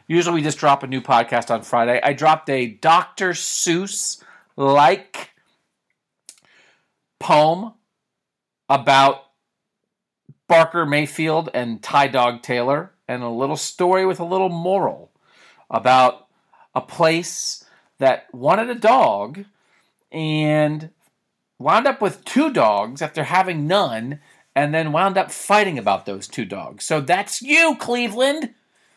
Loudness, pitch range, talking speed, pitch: -19 LUFS, 140-200 Hz, 125 wpm, 160 Hz